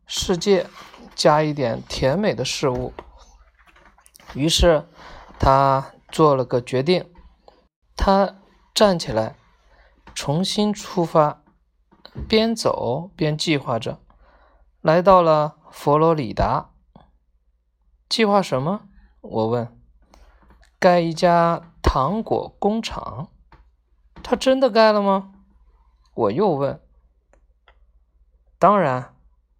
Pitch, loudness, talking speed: 150 Hz, -20 LUFS, 130 characters per minute